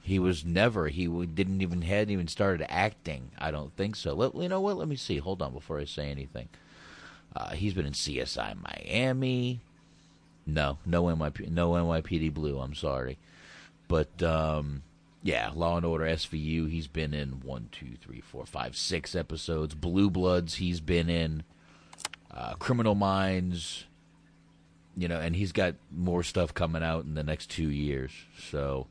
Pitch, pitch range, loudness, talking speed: 85 Hz, 75-90 Hz, -31 LUFS, 170 wpm